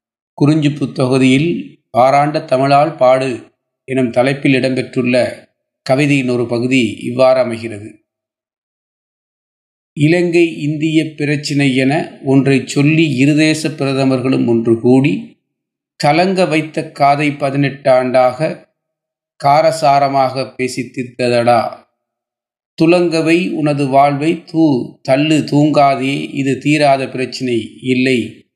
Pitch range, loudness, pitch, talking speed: 130-155 Hz, -14 LUFS, 135 Hz, 90 wpm